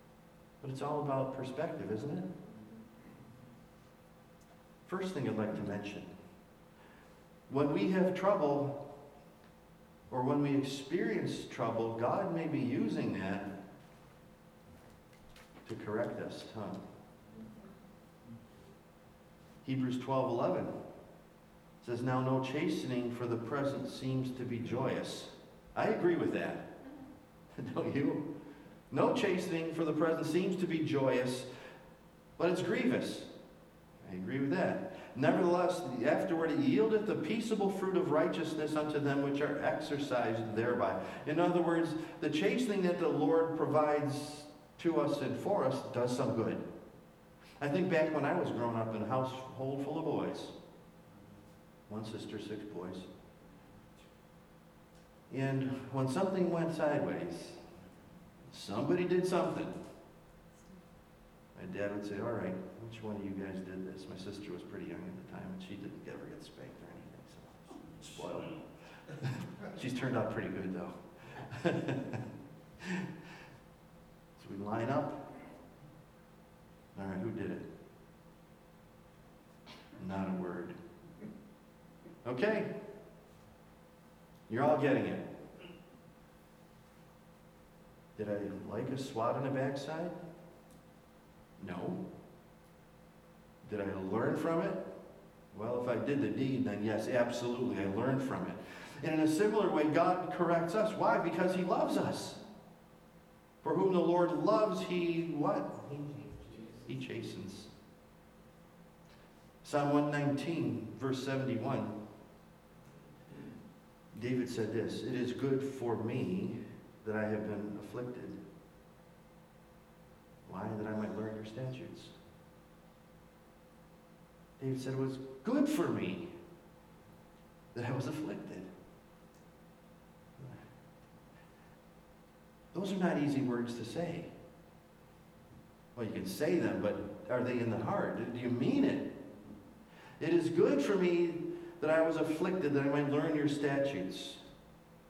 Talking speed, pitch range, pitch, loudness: 125 wpm, 120-170 Hz, 145 Hz, -36 LUFS